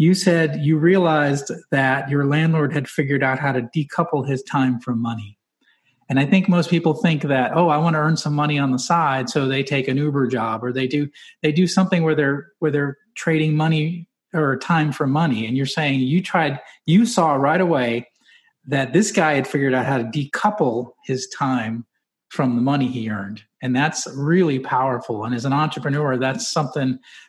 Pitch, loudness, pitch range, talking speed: 145 Hz, -20 LUFS, 130-160 Hz, 200 wpm